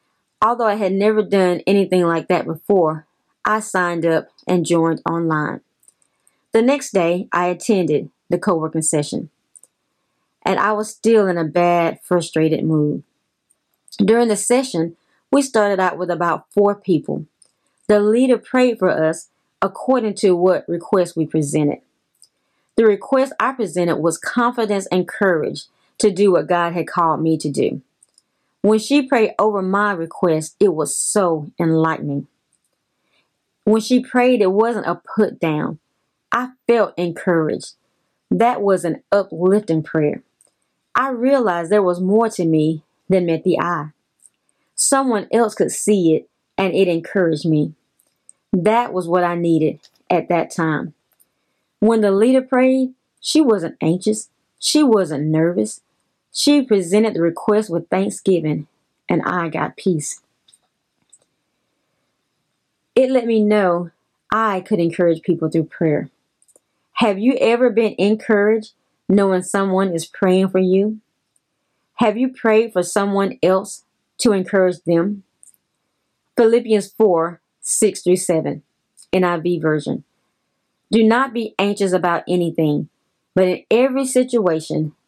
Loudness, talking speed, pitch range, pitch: -18 LUFS, 135 wpm, 170-220 Hz, 190 Hz